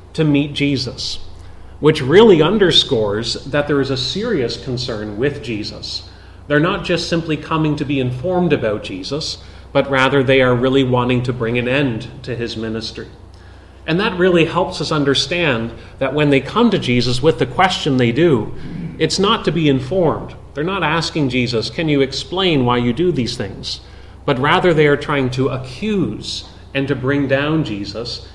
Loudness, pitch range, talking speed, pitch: -17 LUFS, 115-155 Hz, 175 wpm, 135 Hz